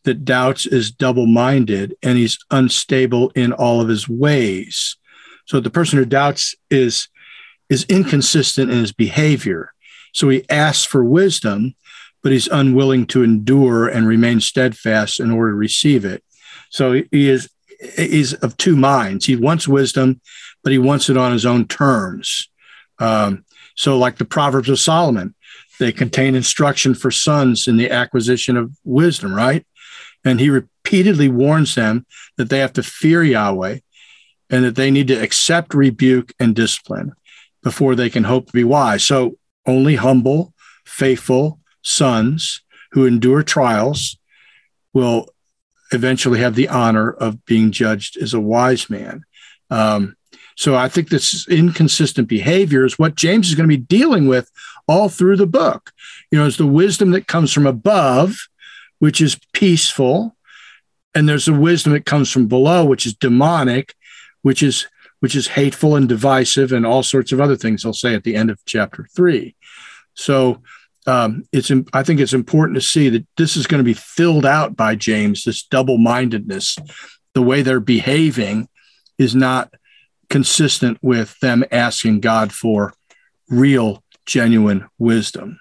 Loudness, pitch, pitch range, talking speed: -15 LUFS, 130 Hz, 120-150 Hz, 155 wpm